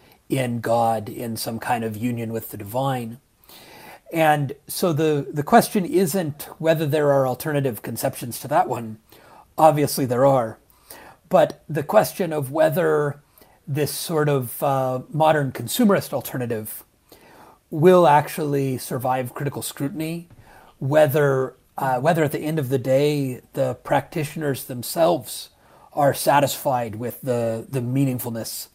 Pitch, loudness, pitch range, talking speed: 140 Hz, -22 LUFS, 120-155 Hz, 130 wpm